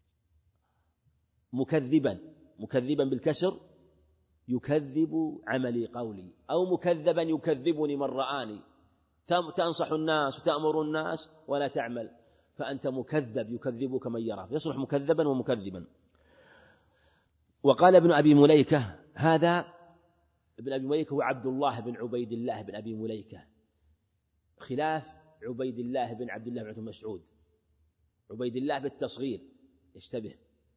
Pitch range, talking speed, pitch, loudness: 110-155 Hz, 105 wpm, 130 Hz, -29 LUFS